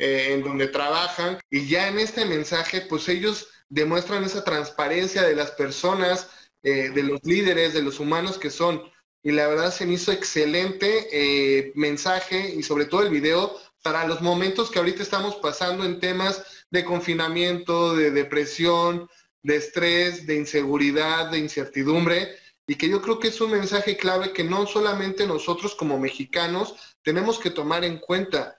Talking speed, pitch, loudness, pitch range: 165 wpm, 175 Hz, -23 LUFS, 150-190 Hz